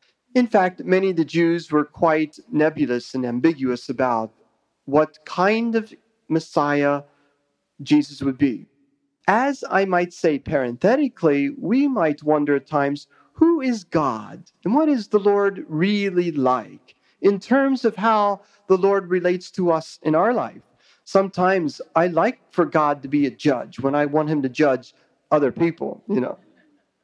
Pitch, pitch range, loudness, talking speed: 170 Hz, 145-205 Hz, -21 LUFS, 155 wpm